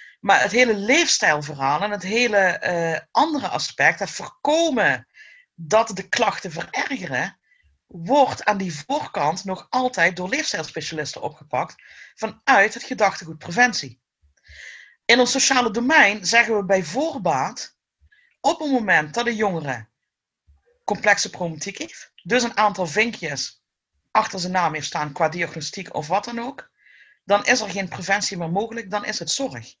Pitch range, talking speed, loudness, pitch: 165-240 Hz, 145 wpm, -21 LUFS, 200 Hz